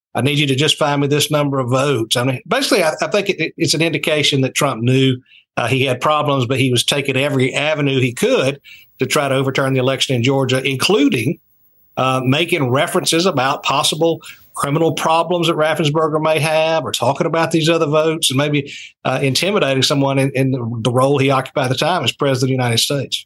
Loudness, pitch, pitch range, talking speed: -16 LUFS, 140 Hz, 130-155 Hz, 215 wpm